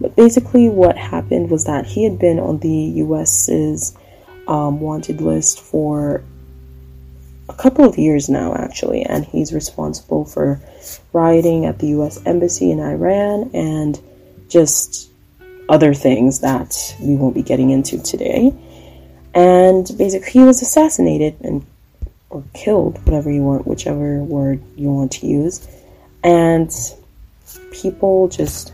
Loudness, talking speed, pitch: -15 LUFS, 135 wpm, 145 Hz